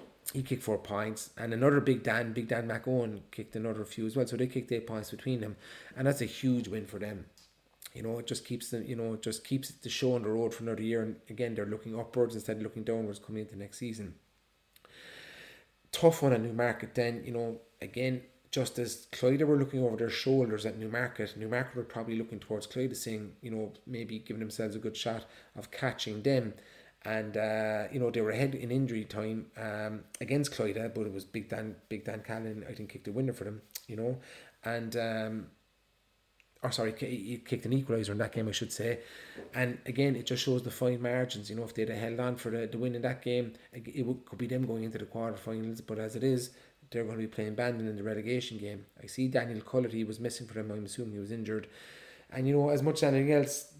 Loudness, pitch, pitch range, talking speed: -34 LUFS, 115 Hz, 110-125 Hz, 235 wpm